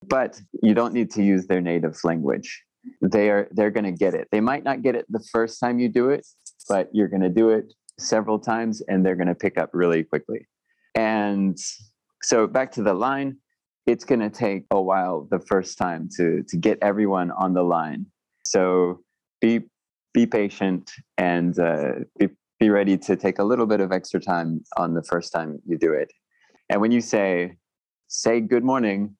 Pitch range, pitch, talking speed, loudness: 90-115 Hz, 100 Hz, 195 wpm, -23 LUFS